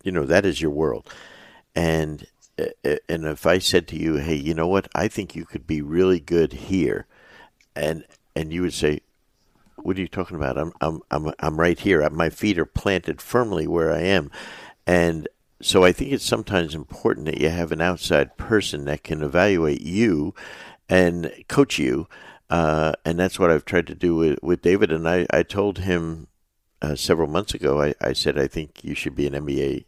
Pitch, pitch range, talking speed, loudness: 85 Hz, 80-90 Hz, 200 wpm, -22 LUFS